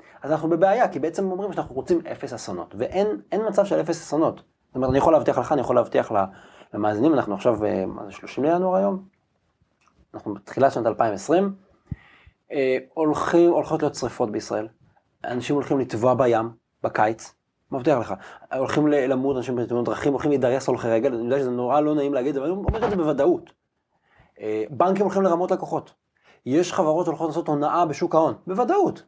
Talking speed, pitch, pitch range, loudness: 175 wpm, 150 Hz, 125-175 Hz, -23 LUFS